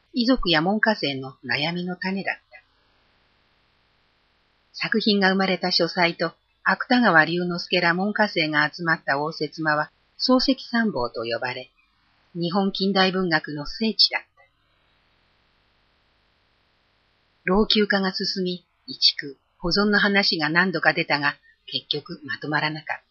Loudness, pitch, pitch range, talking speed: -22 LUFS, 175 Hz, 150-200 Hz, 235 characters per minute